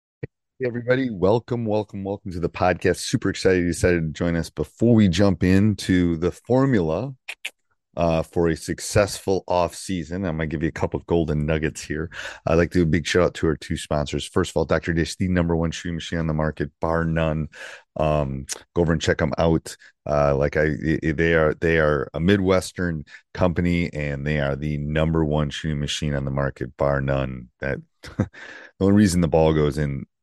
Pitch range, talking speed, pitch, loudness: 75-90 Hz, 205 wpm, 85 Hz, -22 LUFS